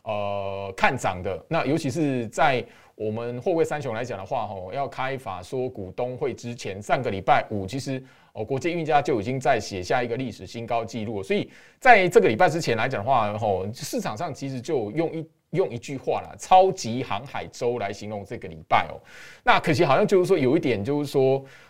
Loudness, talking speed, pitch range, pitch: -24 LUFS, 305 characters per minute, 110-155 Hz, 130 Hz